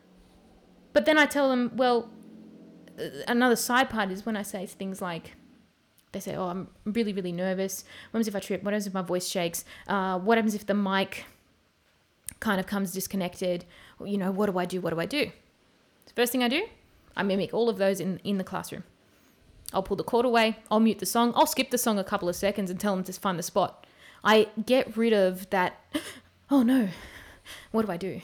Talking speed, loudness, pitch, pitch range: 220 wpm, -27 LUFS, 200 Hz, 185-230 Hz